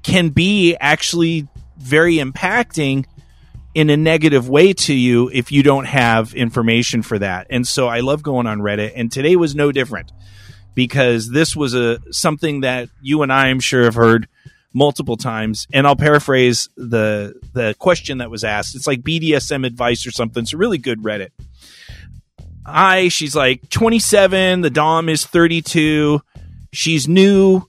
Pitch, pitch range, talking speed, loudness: 135 Hz, 120-160 Hz, 165 wpm, -15 LUFS